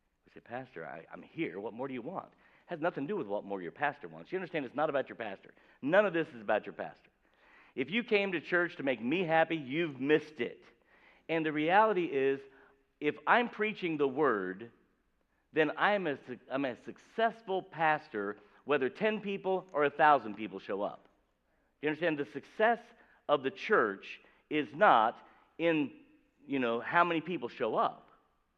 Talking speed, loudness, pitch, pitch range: 185 wpm, -32 LUFS, 155 Hz, 135-195 Hz